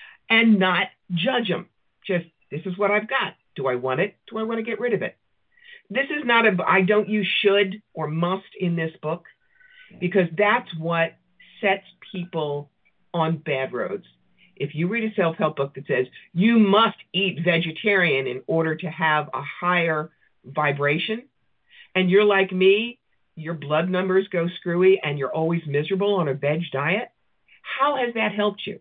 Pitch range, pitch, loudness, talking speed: 160-210 Hz, 185 Hz, -22 LUFS, 175 wpm